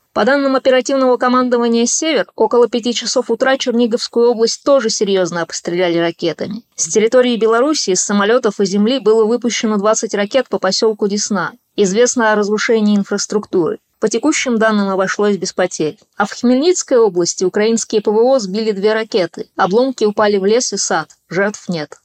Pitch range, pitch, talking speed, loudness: 200-240 Hz, 220 Hz, 150 wpm, -15 LUFS